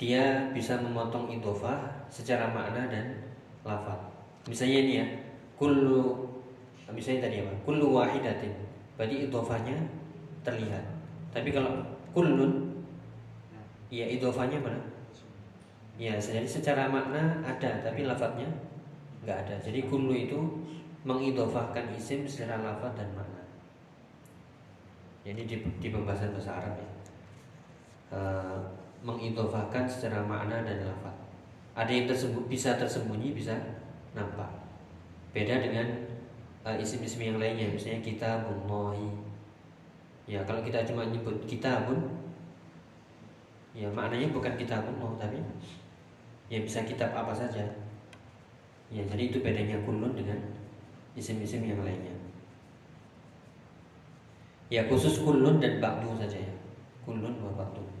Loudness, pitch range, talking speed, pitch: -33 LUFS, 105-130 Hz, 115 wpm, 115 Hz